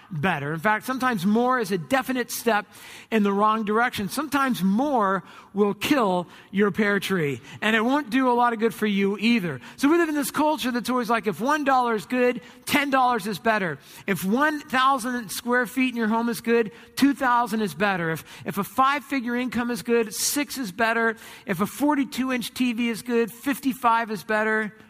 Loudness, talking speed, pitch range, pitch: -24 LUFS, 210 wpm, 210-255 Hz, 235 Hz